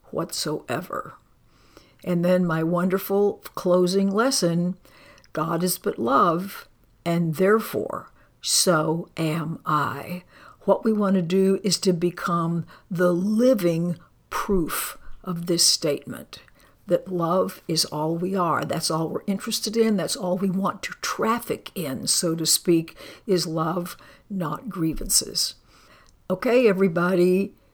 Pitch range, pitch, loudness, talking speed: 165-195 Hz, 180 Hz, -23 LUFS, 125 wpm